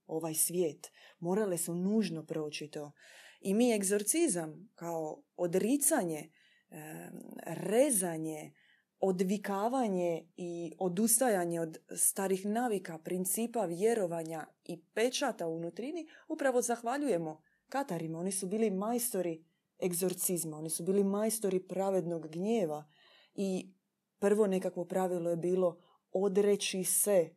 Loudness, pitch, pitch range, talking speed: -33 LUFS, 185 Hz, 170-215 Hz, 105 wpm